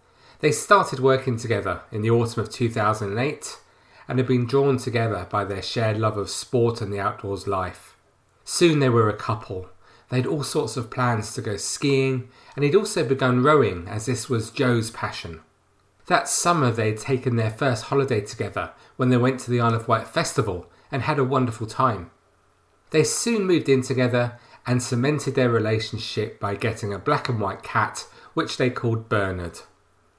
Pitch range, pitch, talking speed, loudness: 105-135 Hz, 120 Hz, 175 wpm, -23 LUFS